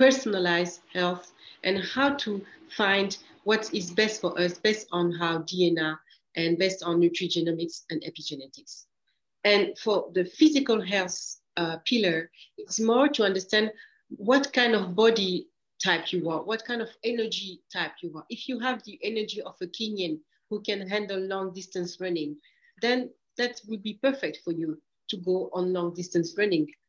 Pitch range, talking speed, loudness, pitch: 175-225 Hz, 165 wpm, -27 LUFS, 195 Hz